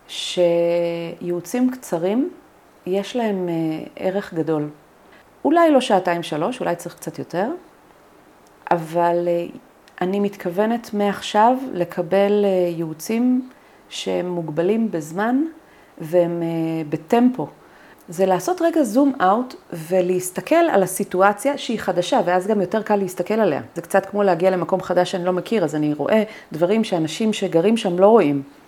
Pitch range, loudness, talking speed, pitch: 170-220 Hz, -20 LUFS, 125 wpm, 190 Hz